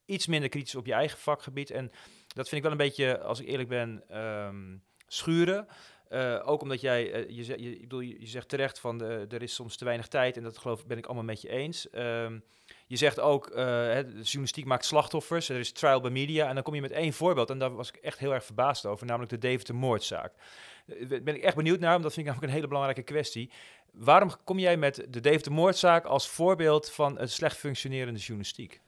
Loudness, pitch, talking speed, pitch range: -30 LUFS, 130 Hz, 240 wpm, 120-150 Hz